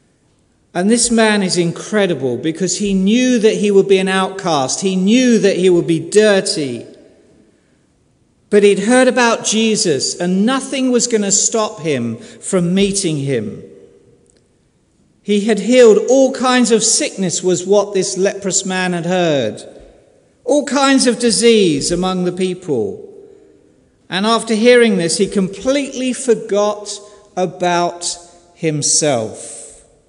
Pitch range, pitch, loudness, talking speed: 180-230 Hz, 200 Hz, -14 LUFS, 130 wpm